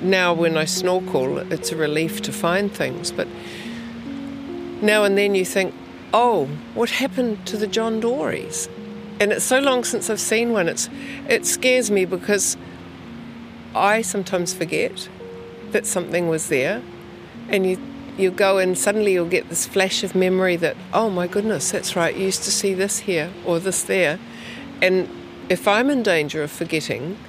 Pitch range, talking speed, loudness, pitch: 180-220 Hz, 170 wpm, -20 LUFS, 195 Hz